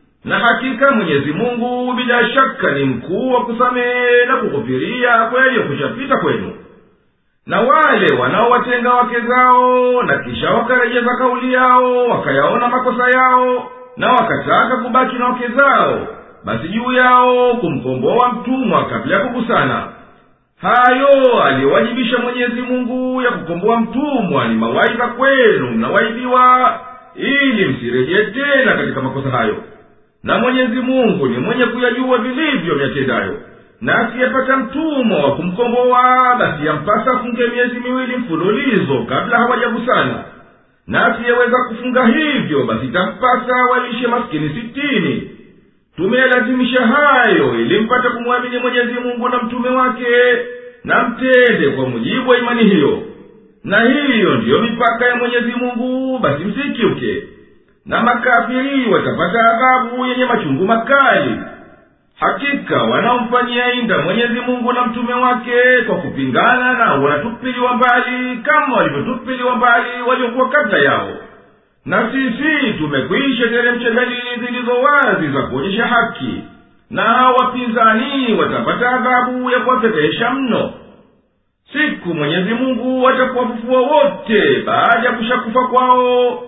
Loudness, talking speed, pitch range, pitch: -14 LUFS, 115 wpm, 235-255 Hz, 245 Hz